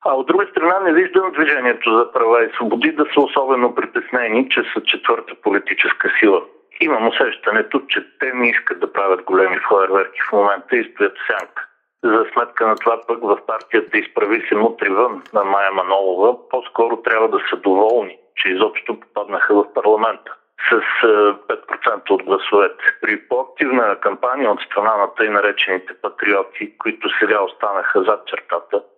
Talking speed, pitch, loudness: 160 wpm, 340 Hz, -17 LUFS